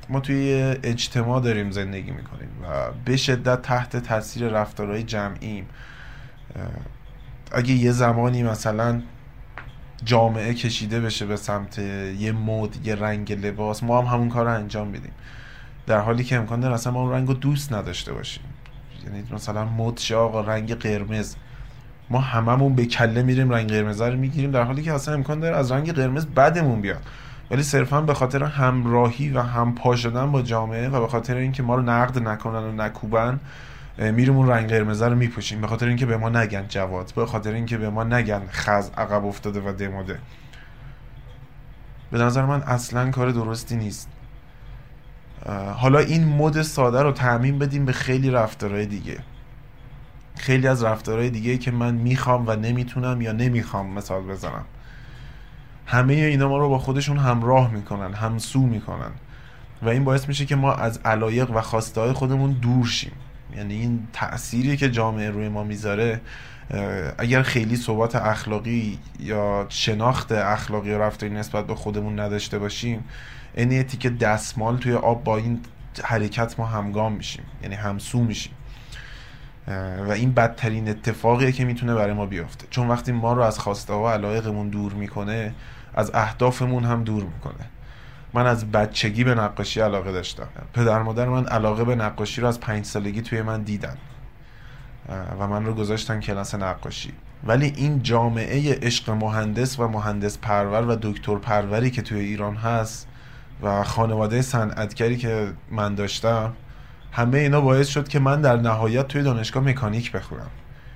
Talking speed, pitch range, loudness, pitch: 160 wpm, 110-130 Hz, -23 LUFS, 120 Hz